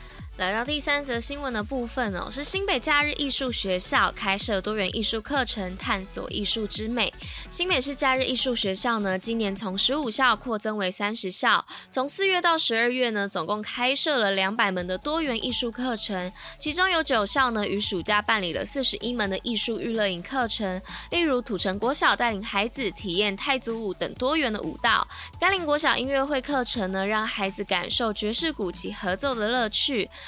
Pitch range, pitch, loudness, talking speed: 200-270 Hz, 230 Hz, -24 LUFS, 295 characters per minute